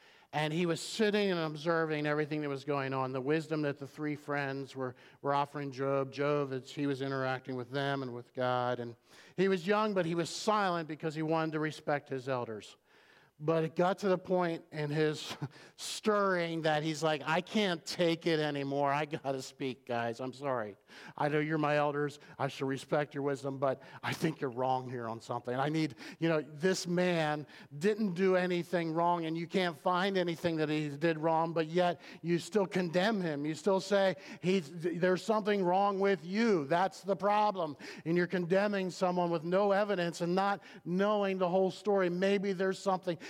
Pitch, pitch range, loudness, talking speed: 160 Hz, 140-185 Hz, -33 LUFS, 195 wpm